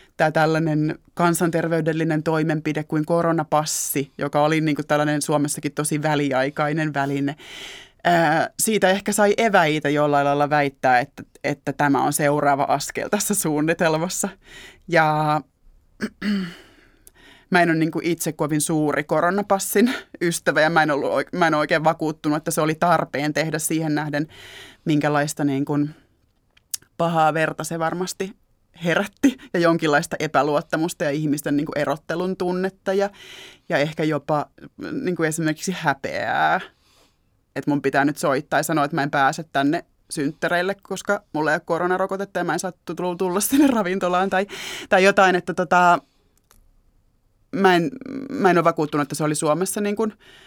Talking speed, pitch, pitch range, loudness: 145 wpm, 160 Hz, 150-180 Hz, -21 LUFS